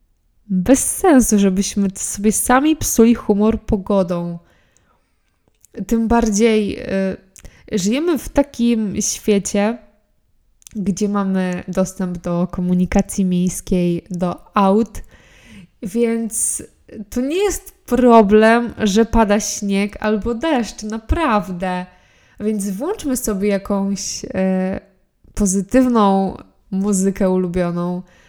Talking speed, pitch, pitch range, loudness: 90 wpm, 205 Hz, 185-225 Hz, -17 LUFS